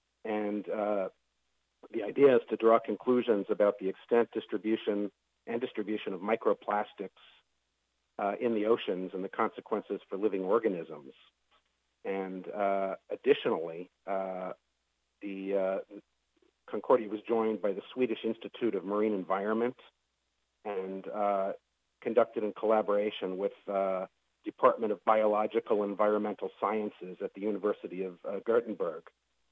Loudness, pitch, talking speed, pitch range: -32 LUFS, 100 Hz, 125 wpm, 95-110 Hz